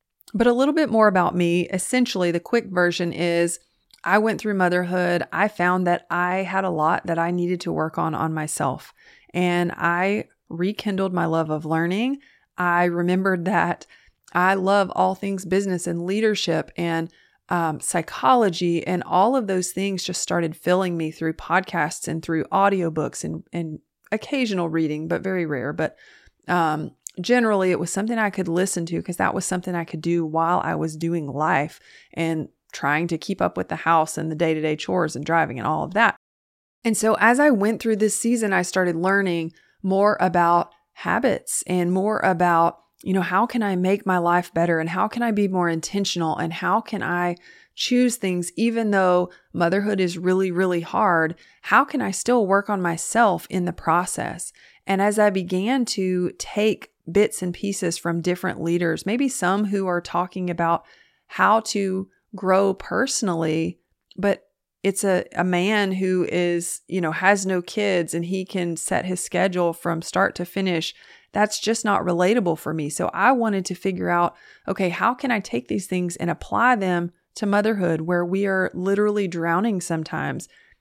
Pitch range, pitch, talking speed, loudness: 170-200 Hz, 180 Hz, 180 wpm, -22 LUFS